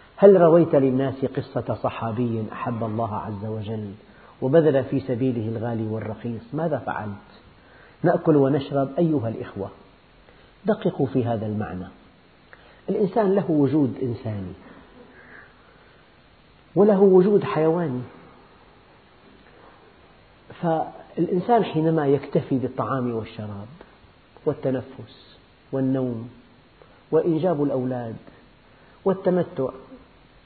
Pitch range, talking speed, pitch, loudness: 115-160 Hz, 80 wpm, 130 Hz, -23 LUFS